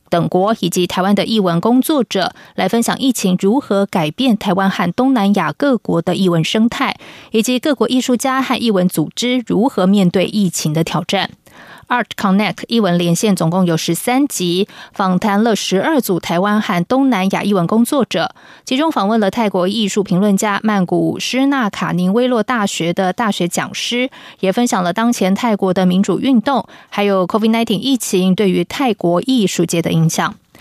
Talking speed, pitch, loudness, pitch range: 295 characters per minute, 200 Hz, -15 LUFS, 185-240 Hz